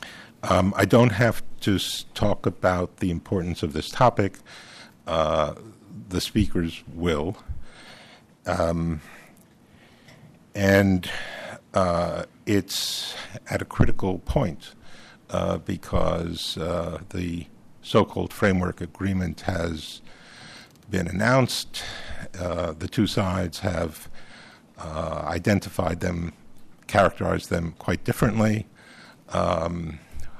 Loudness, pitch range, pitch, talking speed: -25 LUFS, 85-100 Hz, 90 Hz, 95 wpm